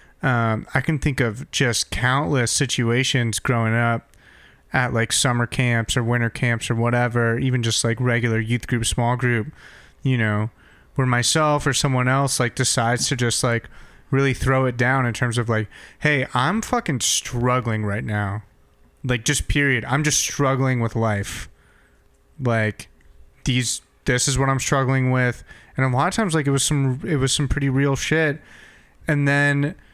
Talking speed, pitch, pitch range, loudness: 170 wpm, 125 Hz, 115-140 Hz, -21 LUFS